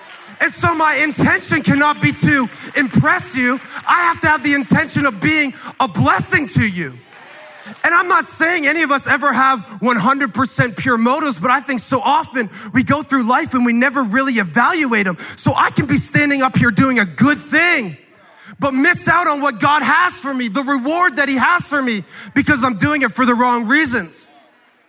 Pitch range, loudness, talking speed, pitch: 245-300 Hz, -15 LUFS, 200 wpm, 275 Hz